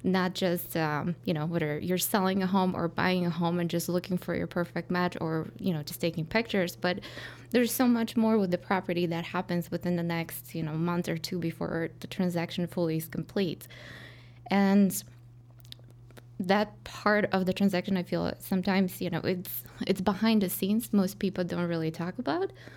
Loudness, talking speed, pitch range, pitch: -29 LUFS, 190 wpm, 165-190 Hz, 175 Hz